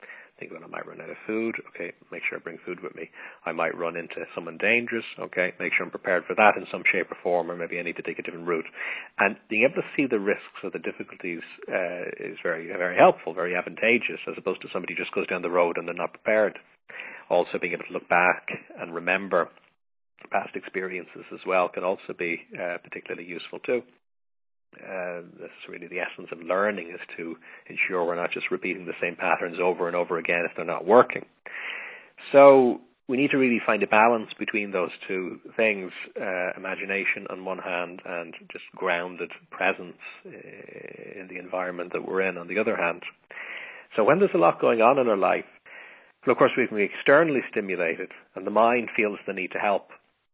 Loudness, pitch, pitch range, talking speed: -25 LUFS, 95 Hz, 85-115 Hz, 210 wpm